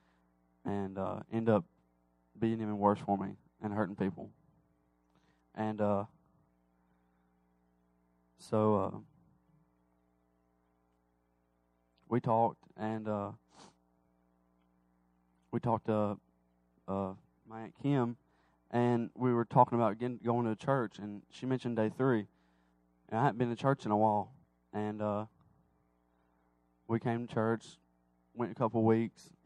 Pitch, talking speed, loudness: 95 Hz, 125 wpm, -34 LUFS